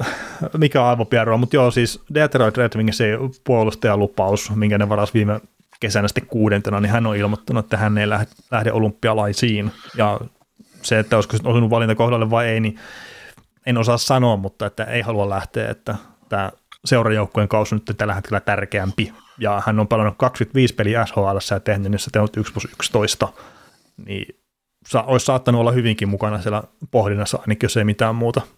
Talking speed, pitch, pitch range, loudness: 175 wpm, 110 Hz, 105-120 Hz, -19 LUFS